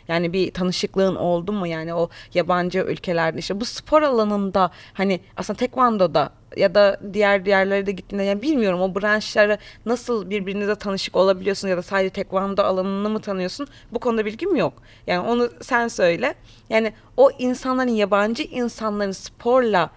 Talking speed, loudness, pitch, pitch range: 155 wpm, -21 LUFS, 200 Hz, 185-225 Hz